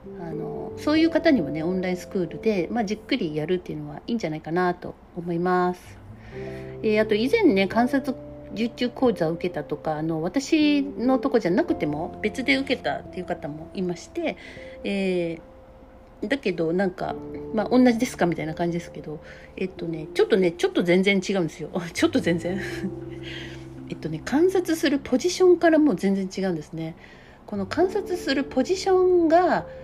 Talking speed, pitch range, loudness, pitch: 370 characters per minute, 165-275 Hz, -24 LUFS, 190 Hz